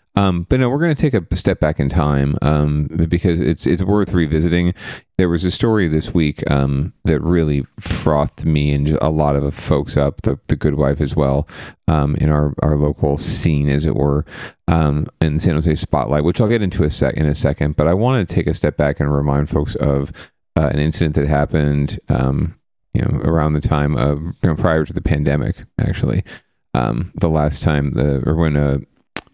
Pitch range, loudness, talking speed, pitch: 75-85 Hz, -17 LUFS, 215 wpm, 75 Hz